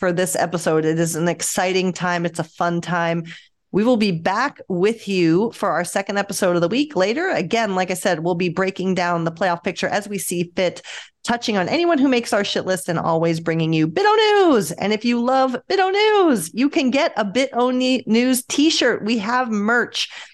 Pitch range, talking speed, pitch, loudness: 175-250 Hz, 210 wpm, 195 Hz, -19 LUFS